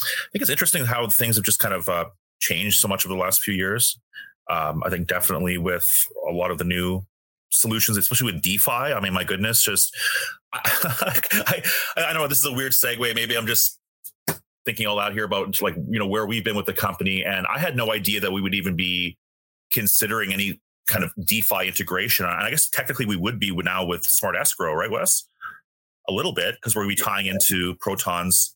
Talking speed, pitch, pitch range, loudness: 220 wpm, 105 Hz, 90-120 Hz, -21 LUFS